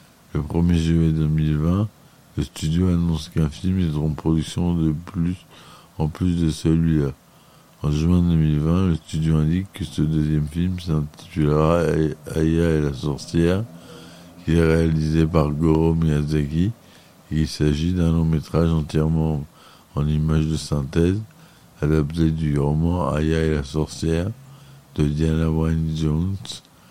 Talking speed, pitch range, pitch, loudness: 135 wpm, 75-85 Hz, 80 Hz, -21 LUFS